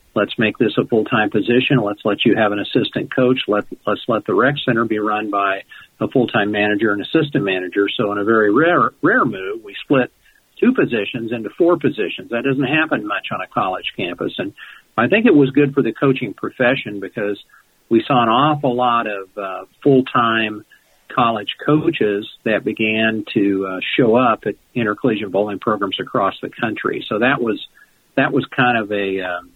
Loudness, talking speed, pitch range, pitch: -18 LUFS, 190 wpm, 105-130 Hz, 115 Hz